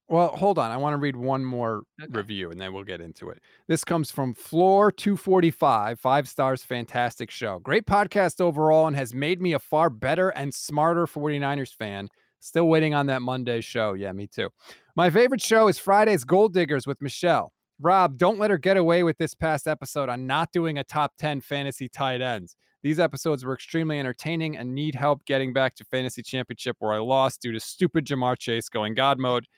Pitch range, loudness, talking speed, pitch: 125-165 Hz, -24 LUFS, 205 wpm, 140 Hz